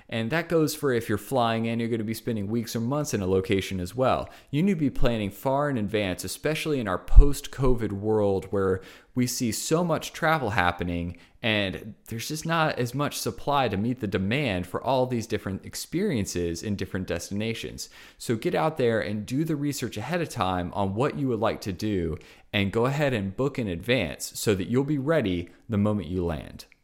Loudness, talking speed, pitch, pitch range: -27 LUFS, 210 wpm, 115 Hz, 95-135 Hz